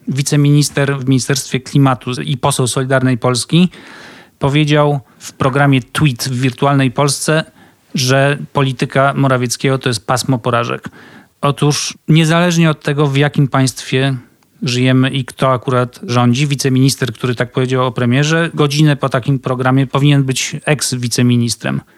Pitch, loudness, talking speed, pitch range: 135 Hz, -14 LUFS, 130 wpm, 130-145 Hz